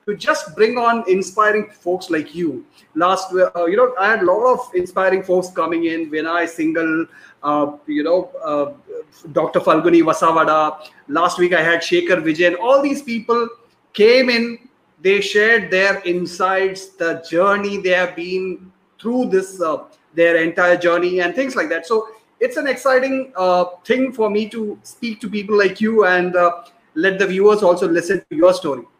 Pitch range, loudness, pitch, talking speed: 175-225 Hz, -17 LUFS, 185 Hz, 180 wpm